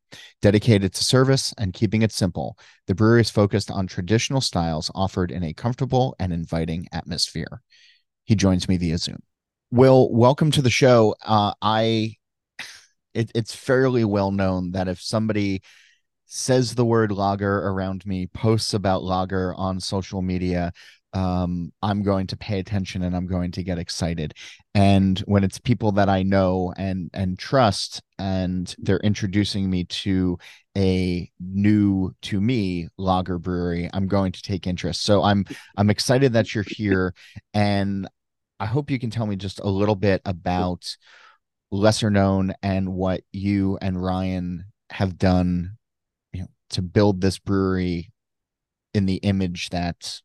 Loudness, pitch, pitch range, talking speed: -22 LUFS, 95 Hz, 90-105 Hz, 155 wpm